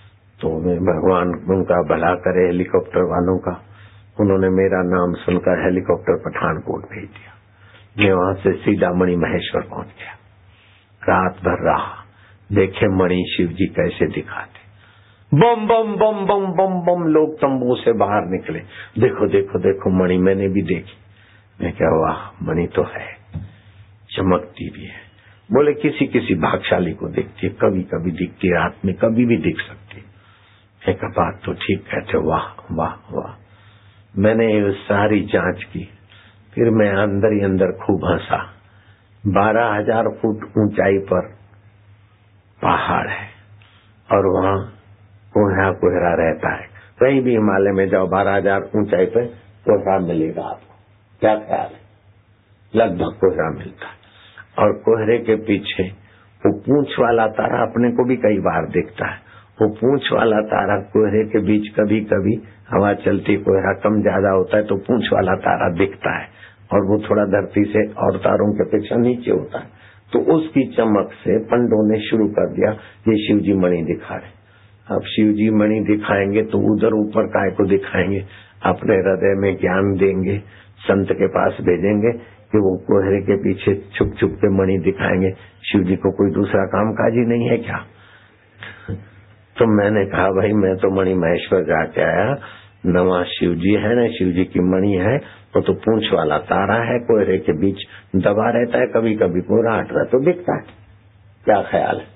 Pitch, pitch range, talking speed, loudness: 100 Hz, 95-110 Hz, 160 wpm, -18 LUFS